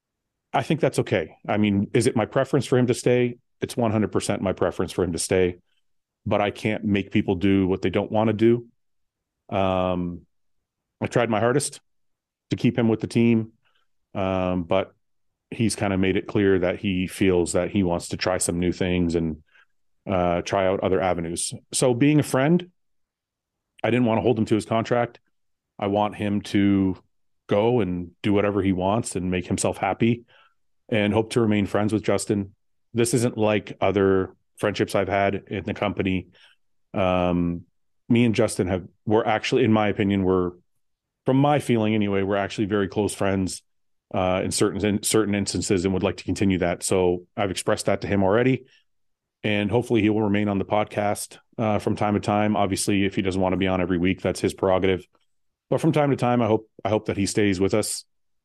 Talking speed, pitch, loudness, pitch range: 195 wpm, 100 Hz, -23 LUFS, 95-110 Hz